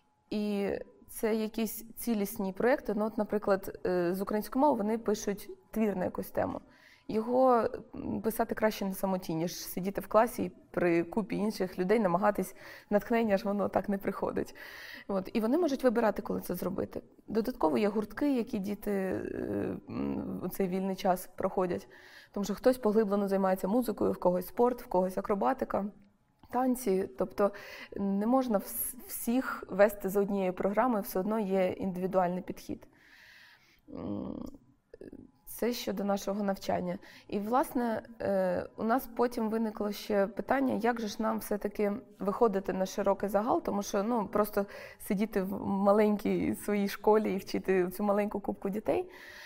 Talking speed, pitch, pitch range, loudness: 140 wpm, 205 Hz, 195-225 Hz, -31 LUFS